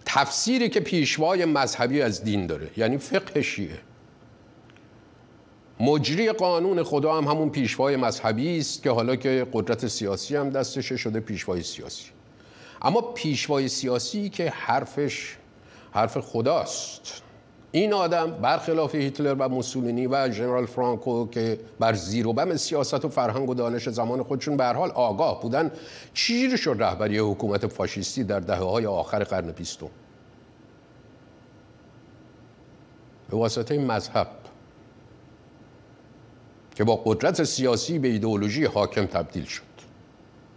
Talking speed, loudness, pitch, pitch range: 125 wpm, -25 LUFS, 125 Hz, 110-145 Hz